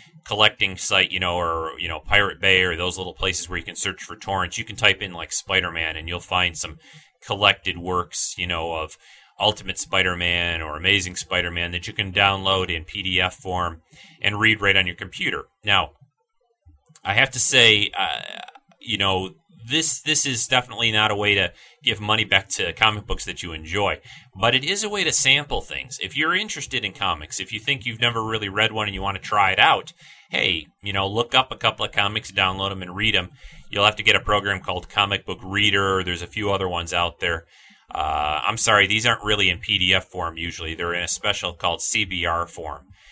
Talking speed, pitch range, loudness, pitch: 220 wpm, 90-110 Hz, -21 LUFS, 95 Hz